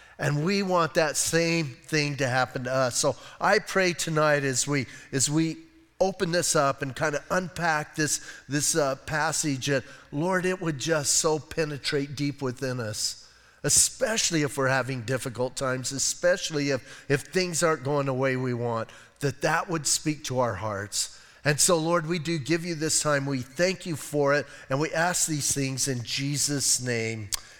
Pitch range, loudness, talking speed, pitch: 135-165 Hz, -26 LUFS, 185 wpm, 145 Hz